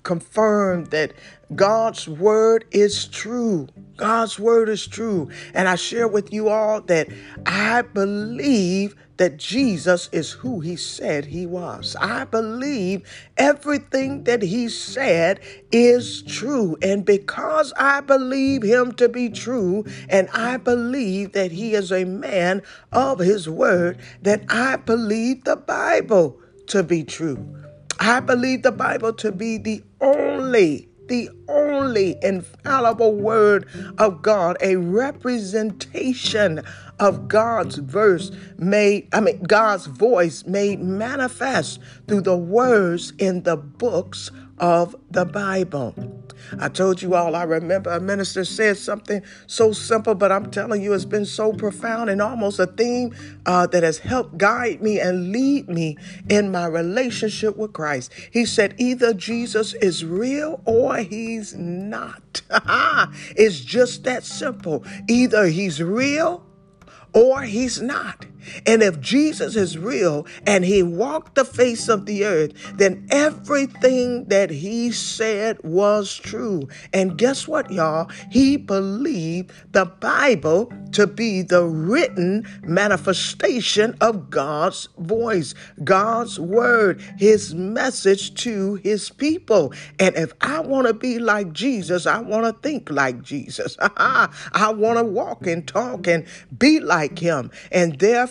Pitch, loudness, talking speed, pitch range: 205 Hz, -20 LUFS, 135 wpm, 180-235 Hz